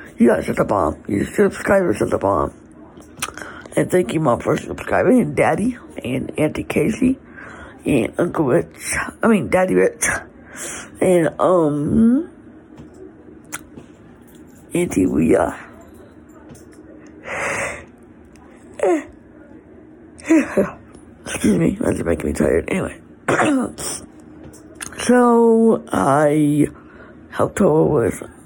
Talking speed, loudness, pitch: 95 wpm, -18 LUFS, 235 Hz